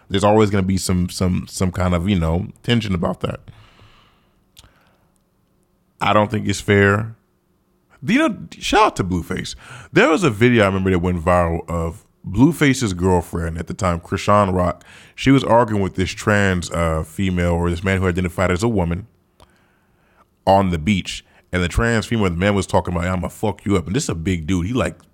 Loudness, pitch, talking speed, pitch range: -19 LUFS, 95 Hz, 205 wpm, 90-105 Hz